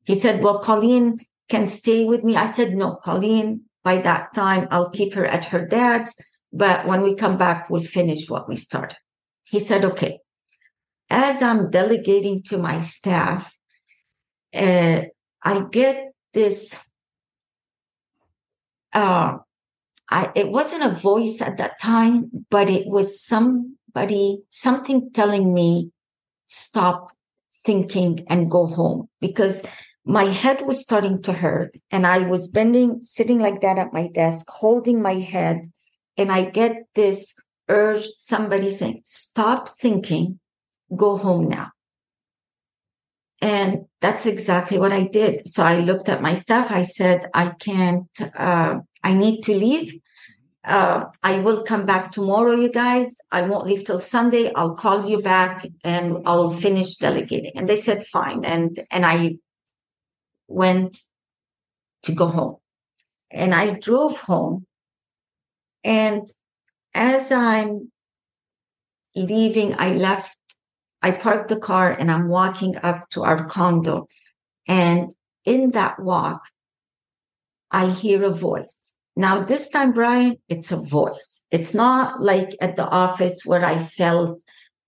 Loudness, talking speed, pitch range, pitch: -20 LUFS, 140 wpm, 180-220 Hz, 195 Hz